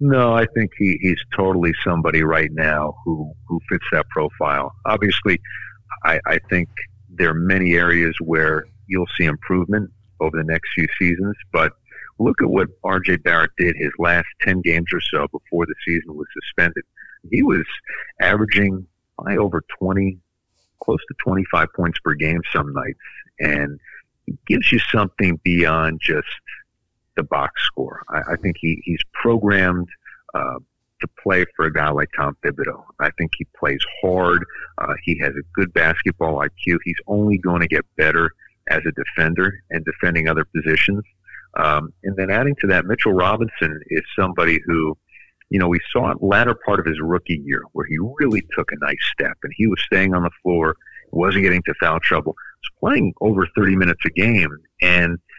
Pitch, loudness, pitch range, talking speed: 90 Hz, -19 LUFS, 80-95 Hz, 180 wpm